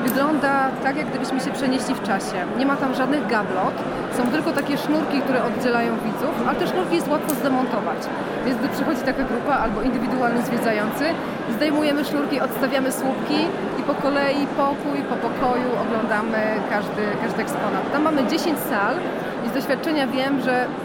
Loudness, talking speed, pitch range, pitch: -22 LUFS, 165 wpm, 240-280 Hz, 265 Hz